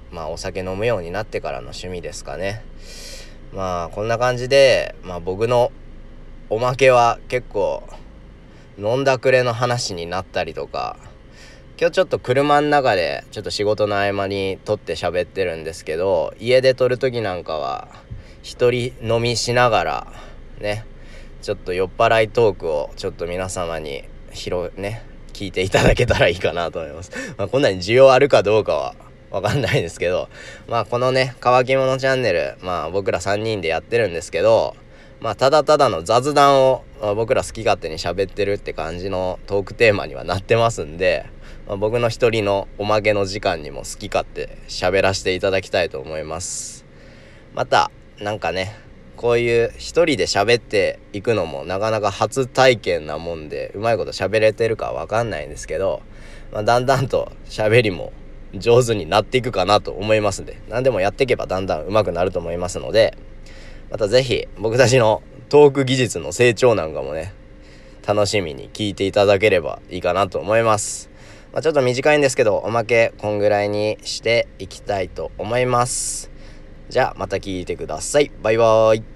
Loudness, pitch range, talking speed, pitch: -19 LUFS, 100-130 Hz, 355 characters per minute, 110 Hz